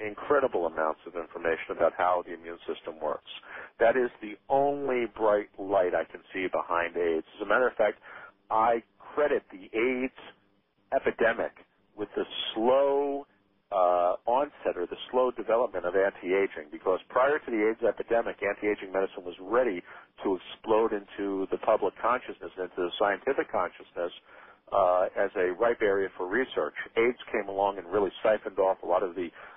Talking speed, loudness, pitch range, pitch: 160 wpm, -29 LUFS, 95-125 Hz, 105 Hz